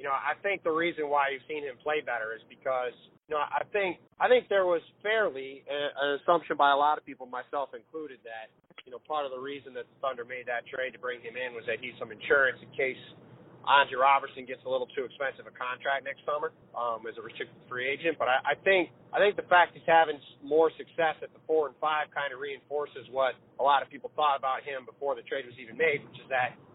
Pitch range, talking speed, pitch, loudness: 140-205 Hz, 245 wpm, 155 Hz, -29 LUFS